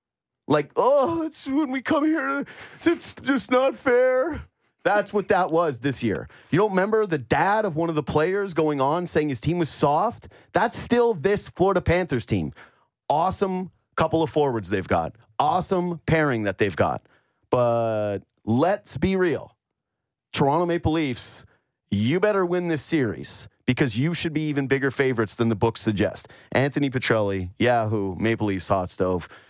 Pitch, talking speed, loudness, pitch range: 155 Hz, 165 wpm, -23 LUFS, 115-190 Hz